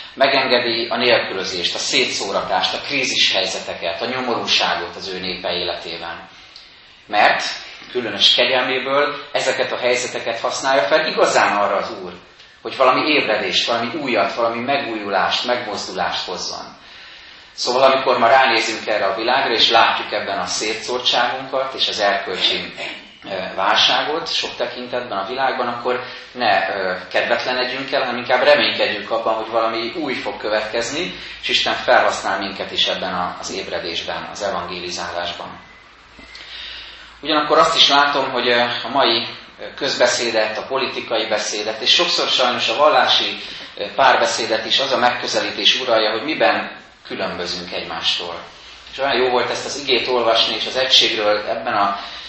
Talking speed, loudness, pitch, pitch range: 135 wpm, -17 LUFS, 120 Hz, 105-125 Hz